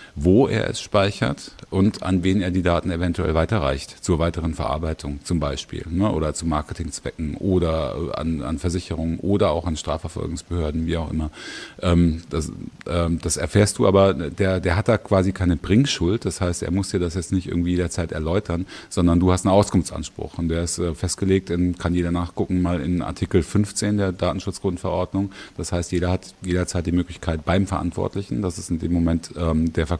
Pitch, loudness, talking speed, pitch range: 90 Hz, -22 LUFS, 185 wpm, 85-95 Hz